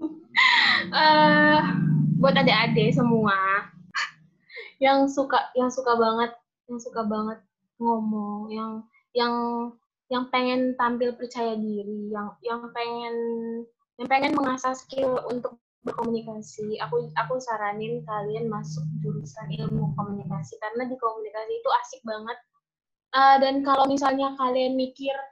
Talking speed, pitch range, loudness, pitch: 115 wpm, 215-260 Hz, -24 LUFS, 235 Hz